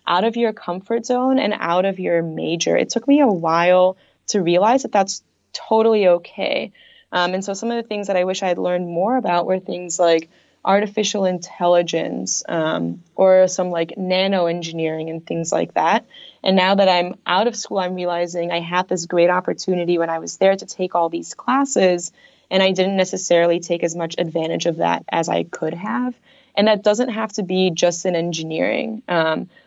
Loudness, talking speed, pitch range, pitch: -19 LUFS, 200 wpm, 170-210 Hz, 185 Hz